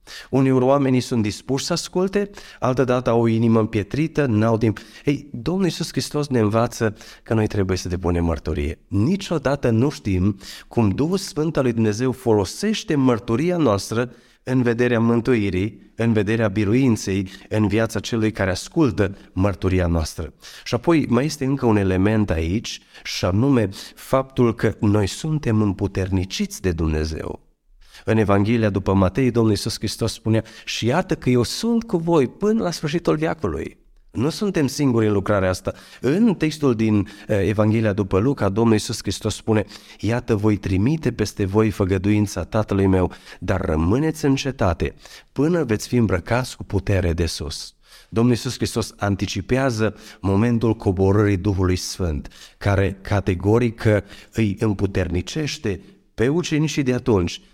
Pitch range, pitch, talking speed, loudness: 100-130 Hz, 110 Hz, 145 wpm, -21 LUFS